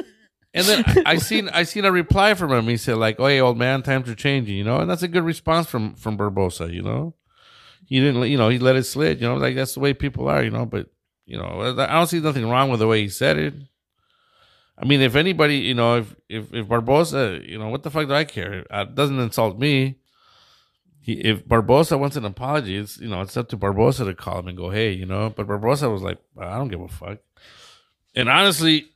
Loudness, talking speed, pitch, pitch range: -20 LUFS, 245 wpm, 125 Hz, 110-145 Hz